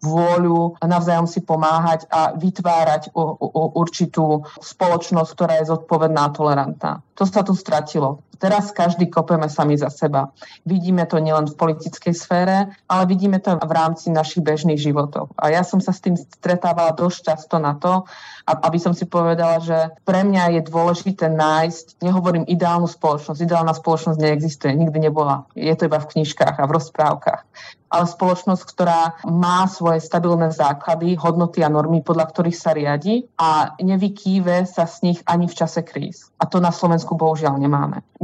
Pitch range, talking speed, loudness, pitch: 160-175 Hz, 170 wpm, -19 LUFS, 165 Hz